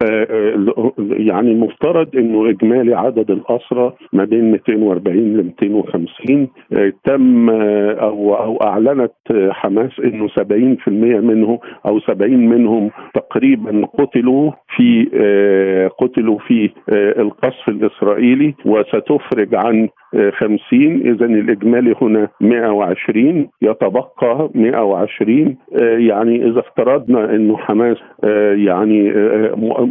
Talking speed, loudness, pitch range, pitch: 90 wpm, -14 LUFS, 105-120 Hz, 115 Hz